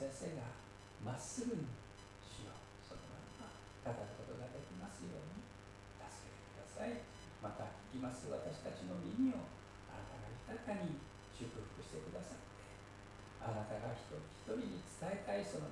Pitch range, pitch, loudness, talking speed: 100-120 Hz, 100 Hz, -48 LUFS, 290 characters per minute